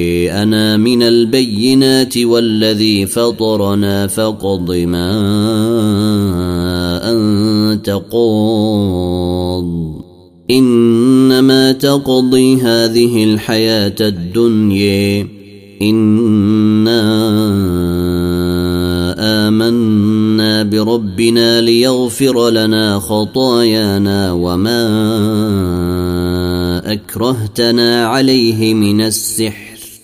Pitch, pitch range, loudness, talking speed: 110 Hz, 100-115 Hz, -12 LUFS, 50 wpm